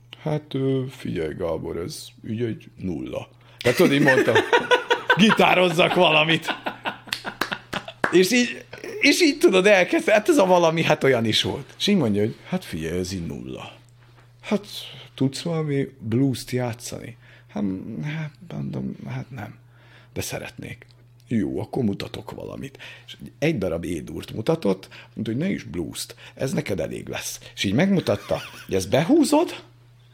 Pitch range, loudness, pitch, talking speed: 120-180 Hz, -22 LUFS, 130 Hz, 140 wpm